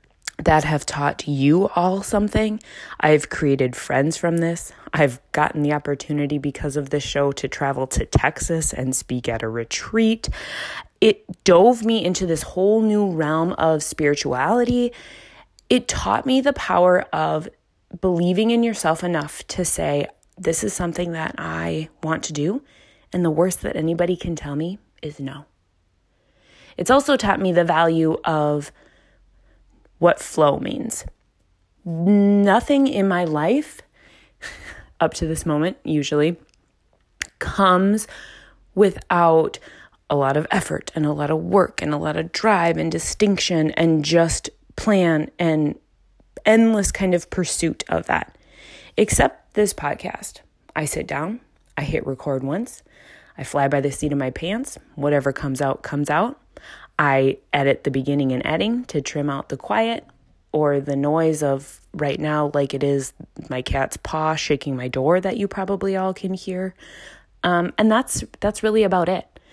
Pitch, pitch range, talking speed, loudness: 160 Hz, 145-190 Hz, 155 wpm, -21 LUFS